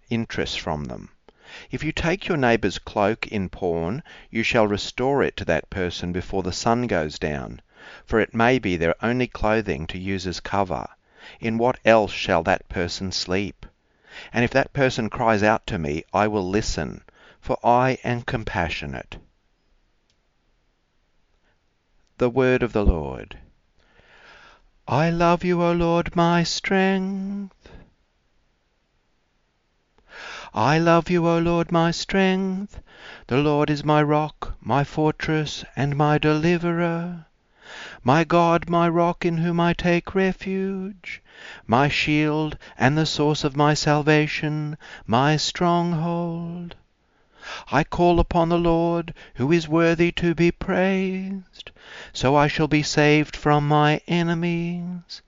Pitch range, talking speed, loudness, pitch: 105-170 Hz, 135 wpm, -22 LUFS, 150 Hz